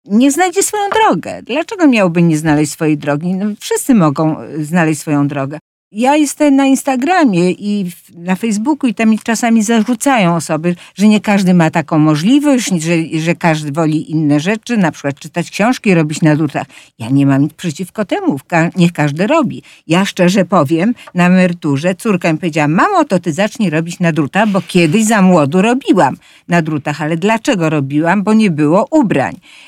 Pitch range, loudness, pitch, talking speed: 160-225 Hz, -13 LUFS, 180 Hz, 170 wpm